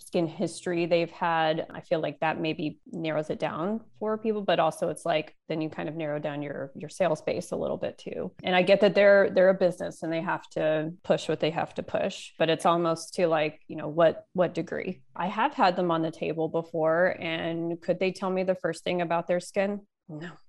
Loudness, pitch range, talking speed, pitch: -27 LUFS, 160-185 Hz, 235 wpm, 170 Hz